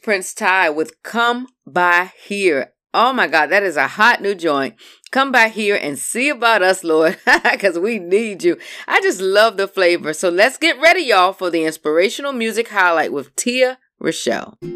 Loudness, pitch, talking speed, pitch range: -16 LUFS, 205 Hz, 185 wpm, 180-250 Hz